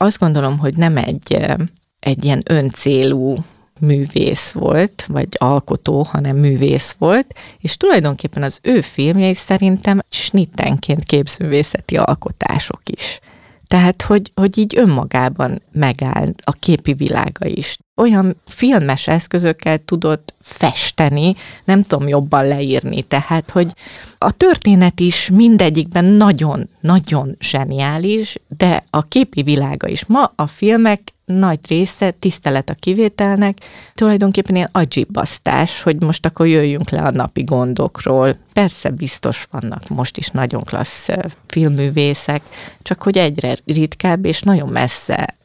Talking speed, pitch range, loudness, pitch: 120 wpm, 145-190 Hz, -15 LUFS, 160 Hz